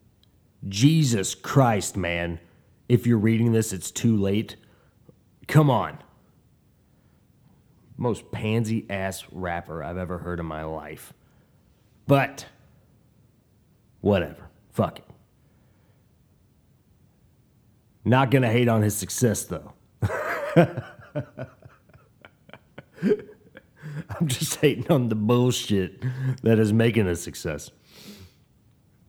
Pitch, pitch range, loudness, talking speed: 110 Hz, 95-125 Hz, -24 LUFS, 90 wpm